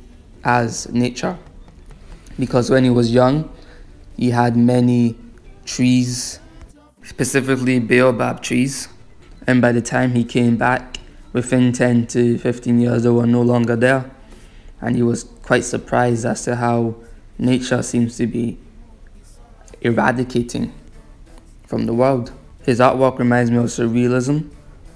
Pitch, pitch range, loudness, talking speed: 120 Hz, 120-125 Hz, -18 LUFS, 125 wpm